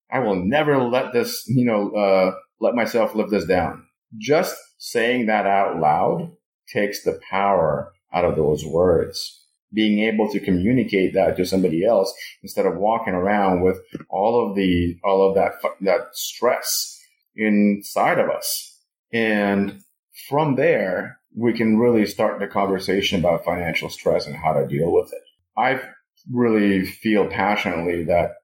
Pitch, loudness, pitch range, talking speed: 105 Hz, -21 LUFS, 95-130 Hz, 150 wpm